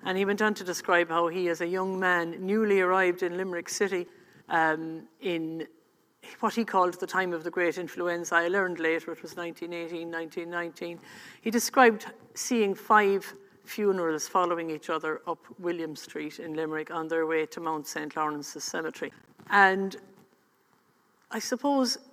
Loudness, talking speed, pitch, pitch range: -28 LUFS, 160 wpm, 175 Hz, 165-195 Hz